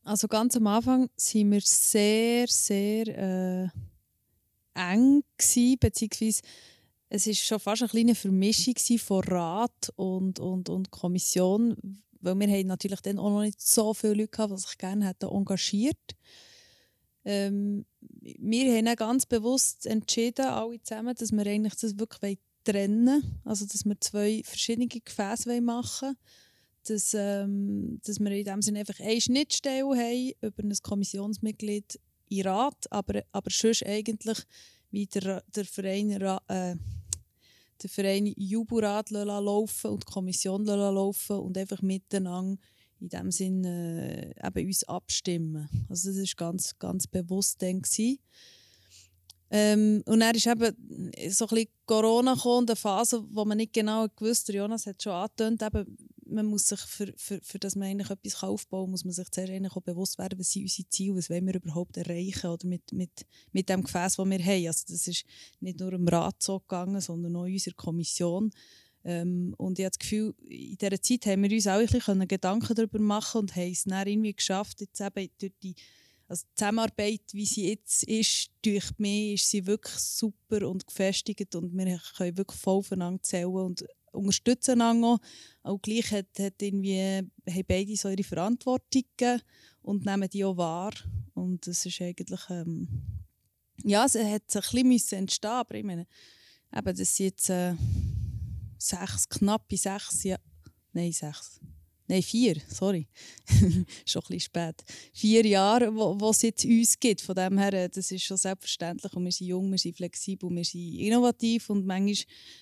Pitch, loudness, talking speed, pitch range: 200 Hz, -28 LUFS, 160 wpm, 185-220 Hz